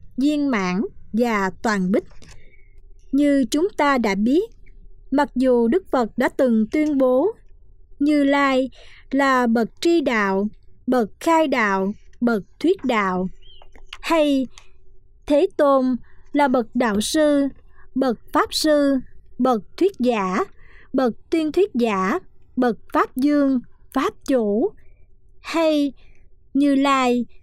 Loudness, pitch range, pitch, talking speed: -20 LUFS, 235-295 Hz, 265 Hz, 120 wpm